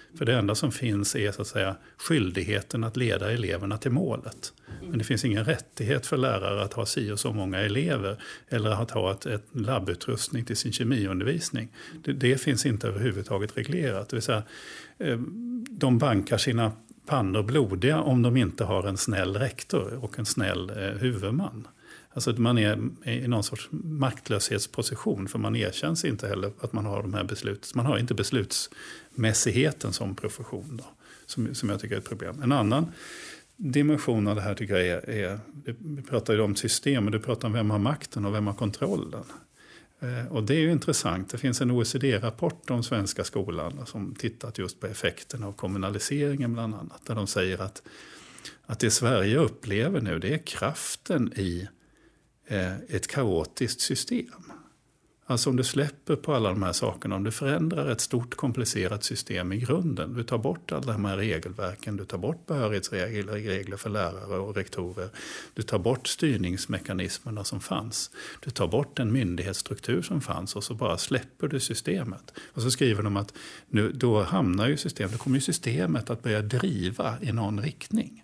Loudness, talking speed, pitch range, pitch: -28 LUFS, 175 wpm, 100-130 Hz, 115 Hz